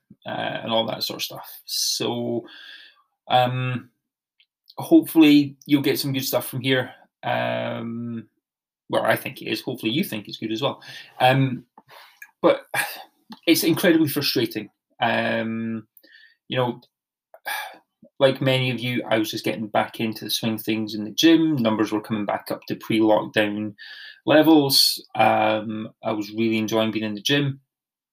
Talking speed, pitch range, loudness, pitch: 155 wpm, 110-140 Hz, -22 LUFS, 115 Hz